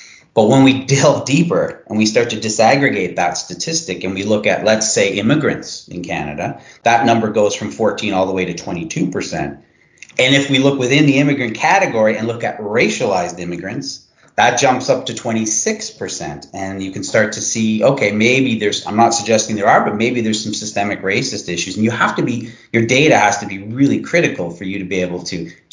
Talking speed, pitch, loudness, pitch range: 205 wpm, 110 Hz, -16 LUFS, 100-120 Hz